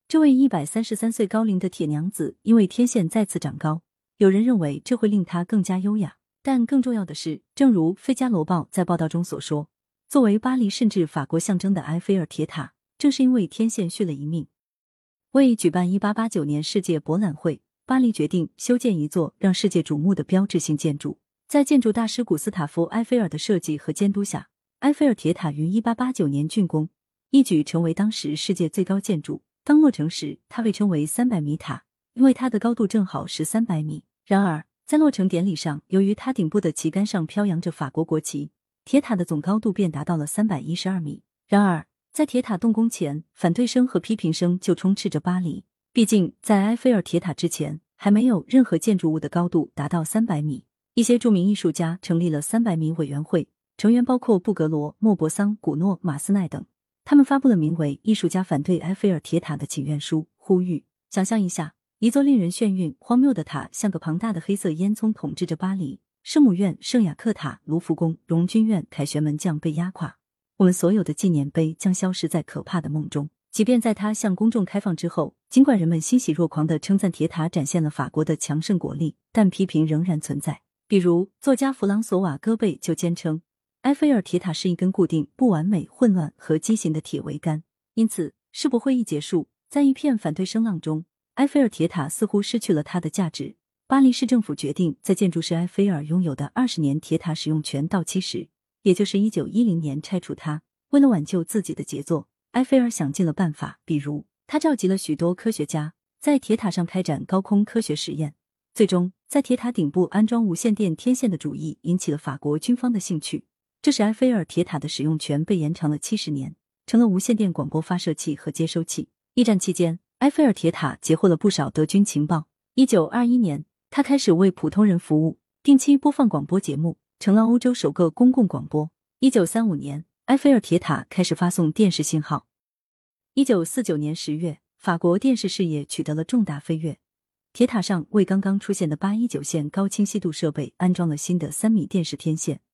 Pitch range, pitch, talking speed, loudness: 155-220 Hz, 180 Hz, 315 characters per minute, -22 LUFS